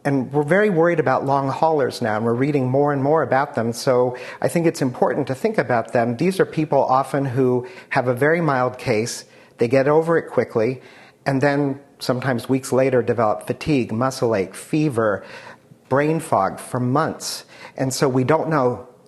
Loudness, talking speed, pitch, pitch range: -20 LUFS, 185 wpm, 135 Hz, 125-155 Hz